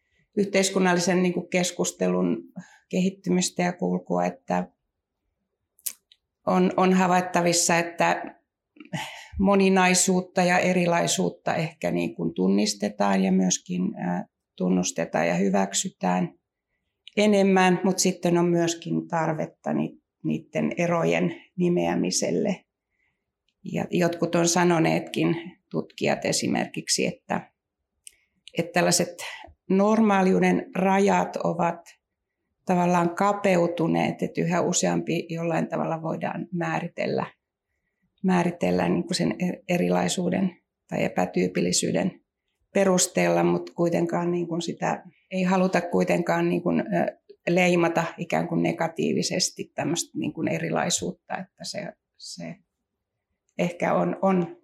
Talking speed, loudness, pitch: 85 wpm, -24 LUFS, 175 Hz